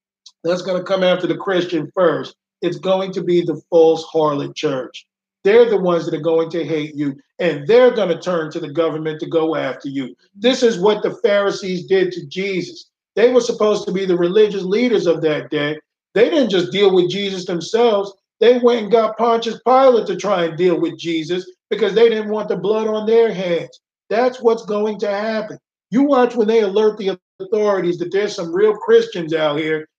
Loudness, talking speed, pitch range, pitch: -17 LUFS, 205 wpm, 170-220 Hz, 190 Hz